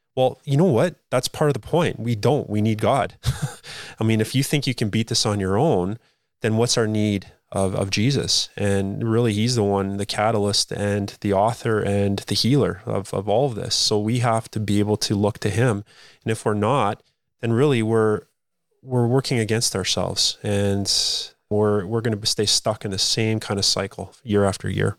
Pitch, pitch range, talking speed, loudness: 110 Hz, 100-120 Hz, 210 wpm, -21 LUFS